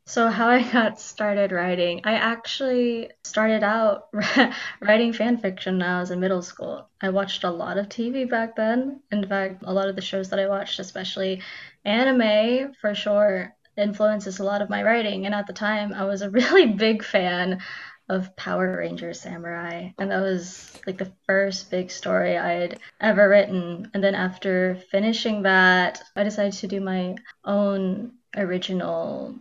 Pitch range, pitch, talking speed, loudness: 185-220 Hz, 200 Hz, 170 wpm, -23 LUFS